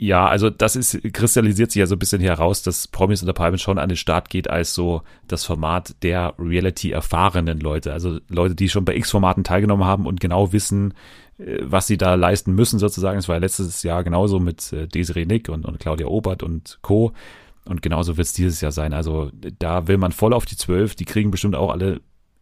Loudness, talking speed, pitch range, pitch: -20 LUFS, 210 wpm, 85-100 Hz, 95 Hz